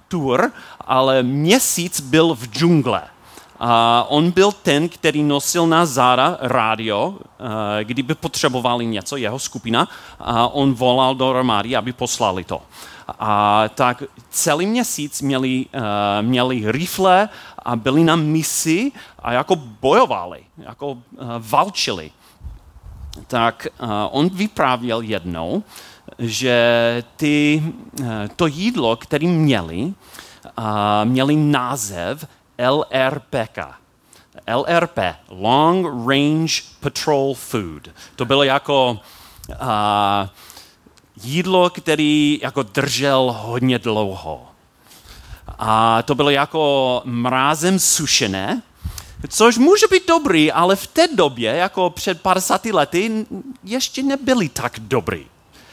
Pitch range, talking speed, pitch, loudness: 115-165 Hz, 100 wpm, 135 Hz, -18 LUFS